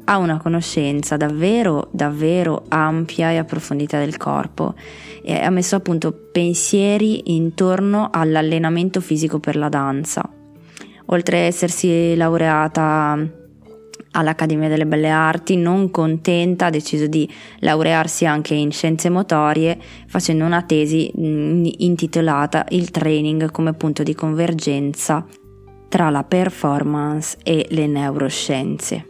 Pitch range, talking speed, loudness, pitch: 150-175 Hz, 115 wpm, -18 LUFS, 160 Hz